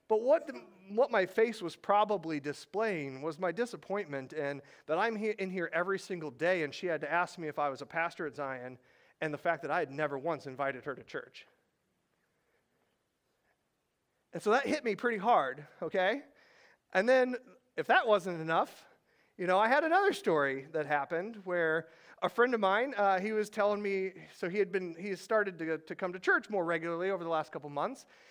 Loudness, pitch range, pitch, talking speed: -33 LUFS, 160-210 Hz, 180 Hz, 205 wpm